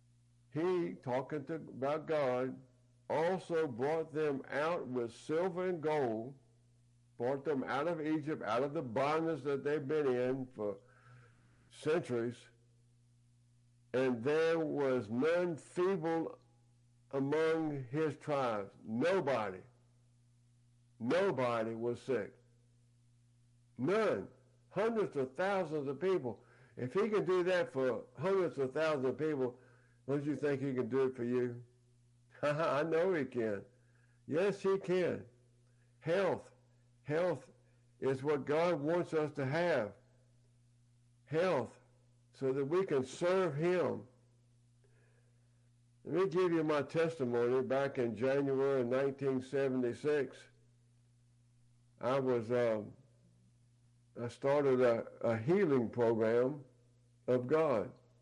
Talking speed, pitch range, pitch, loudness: 115 wpm, 120-150 Hz, 125 Hz, -36 LUFS